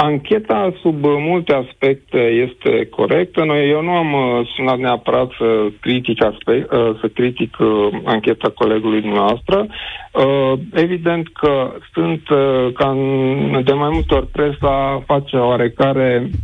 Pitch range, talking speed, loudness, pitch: 120-150 Hz, 105 wpm, -16 LUFS, 135 Hz